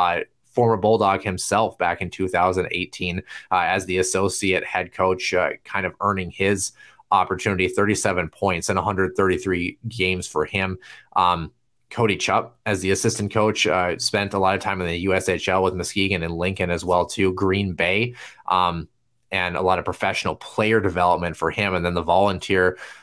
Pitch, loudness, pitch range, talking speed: 95 Hz, -22 LUFS, 90-100 Hz, 170 wpm